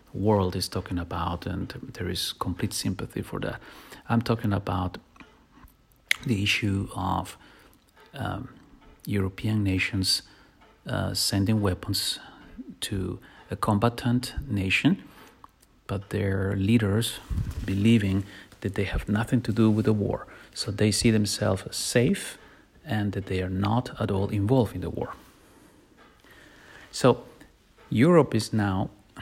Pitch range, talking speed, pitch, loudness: 95-110 Hz, 125 wpm, 100 Hz, -27 LUFS